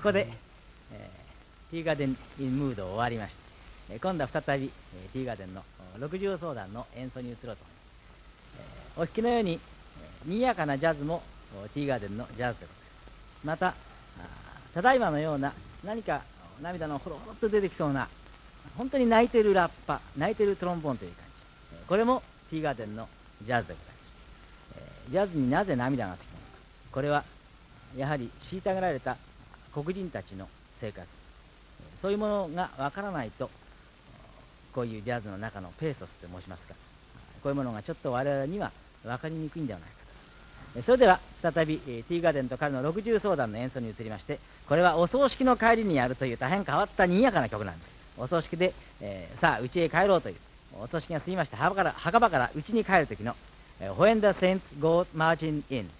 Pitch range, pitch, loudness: 115-180 Hz, 140 Hz, -29 LUFS